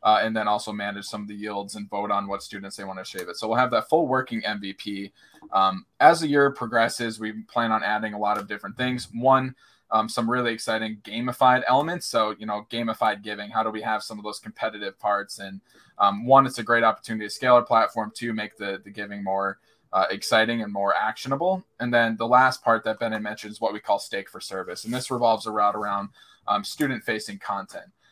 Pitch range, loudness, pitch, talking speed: 105-120 Hz, -24 LUFS, 110 Hz, 225 wpm